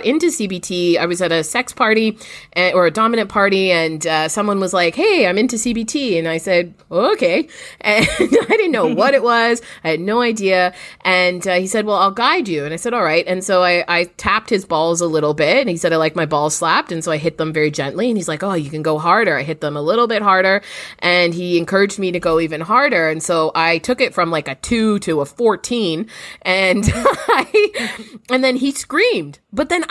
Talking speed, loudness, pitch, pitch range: 240 wpm, -16 LUFS, 185 Hz, 165-225 Hz